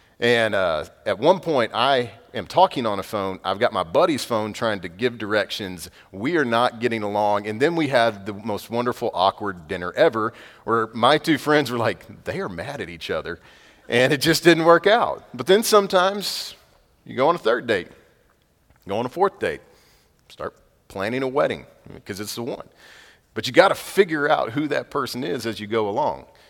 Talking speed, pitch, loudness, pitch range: 200 wpm, 120 Hz, -21 LUFS, 105-150 Hz